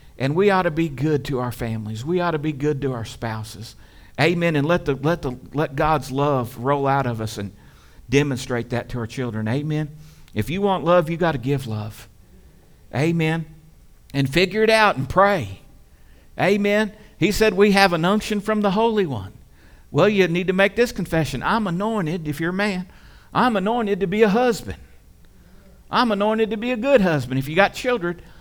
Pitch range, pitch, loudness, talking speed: 125-195 Hz, 155 Hz, -21 LUFS, 200 wpm